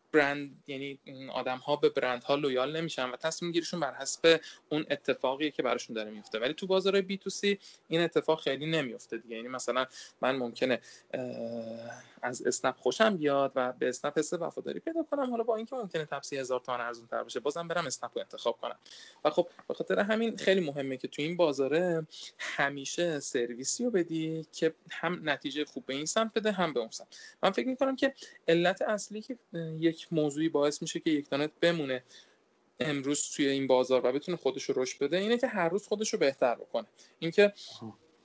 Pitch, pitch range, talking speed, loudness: 155 Hz, 135-180 Hz, 190 wpm, -31 LUFS